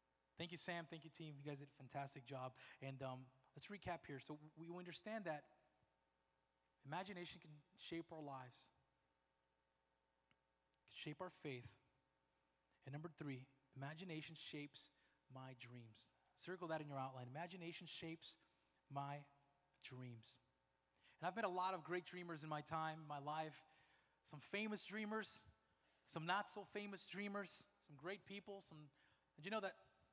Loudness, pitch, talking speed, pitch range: -52 LUFS, 150 Hz, 150 wpm, 125-175 Hz